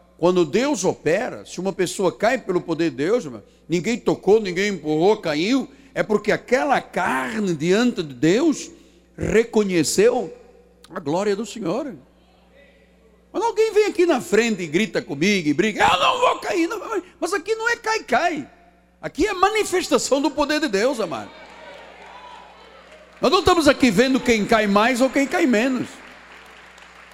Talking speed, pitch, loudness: 155 wpm, 240 Hz, -20 LUFS